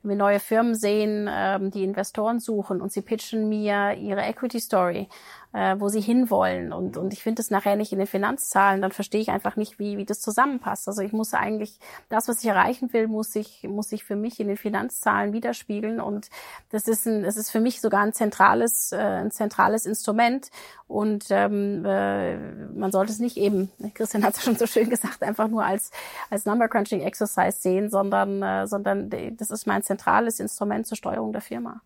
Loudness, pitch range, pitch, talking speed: -25 LUFS, 195-225 Hz, 210 Hz, 200 wpm